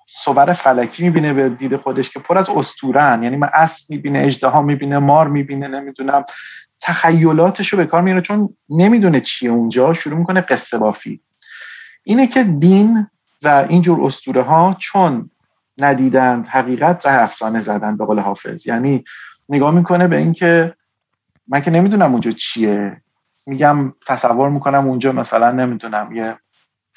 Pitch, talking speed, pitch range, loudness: 145 Hz, 145 wpm, 130-175 Hz, -15 LUFS